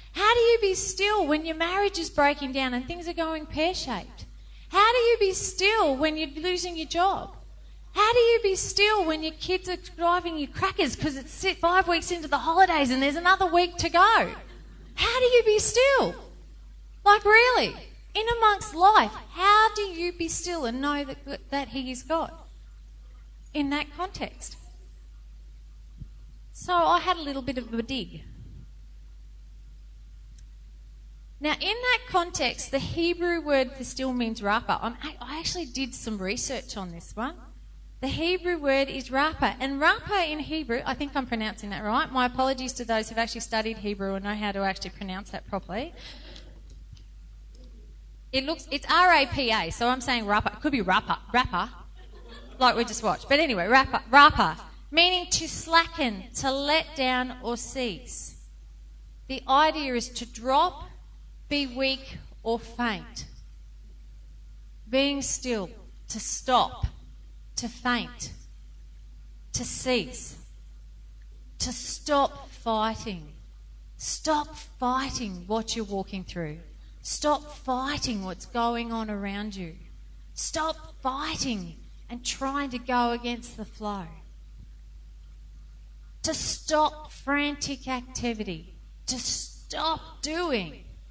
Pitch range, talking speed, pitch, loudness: 210-325 Hz, 140 wpm, 265 Hz, -25 LUFS